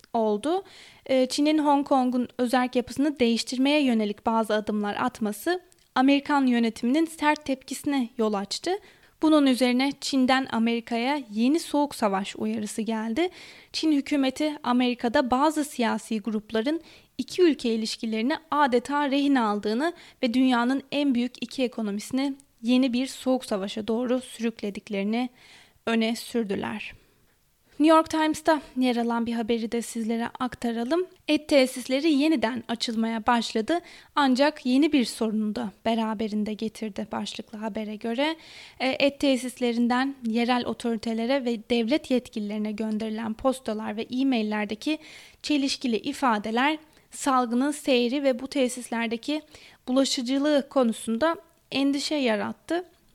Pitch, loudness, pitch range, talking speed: 250 Hz, -26 LUFS, 225-285 Hz, 110 wpm